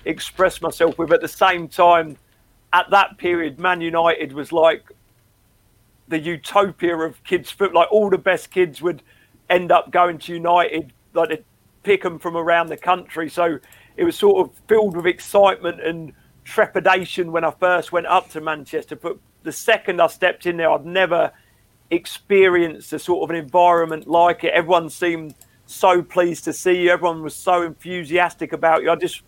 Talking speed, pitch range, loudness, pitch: 180 wpm, 160-180 Hz, -19 LUFS, 170 Hz